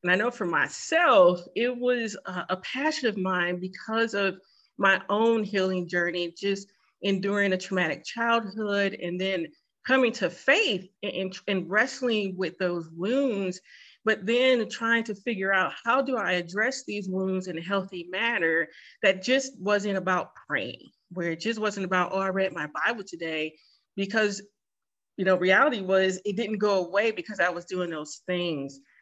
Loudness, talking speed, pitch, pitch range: -26 LUFS, 165 wpm, 195 Hz, 180-220 Hz